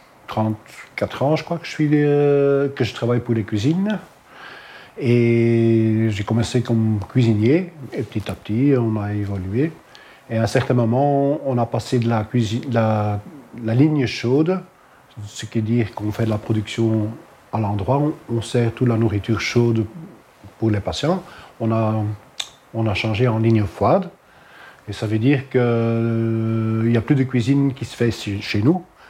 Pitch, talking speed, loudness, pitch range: 115 Hz, 180 wpm, -20 LUFS, 110-135 Hz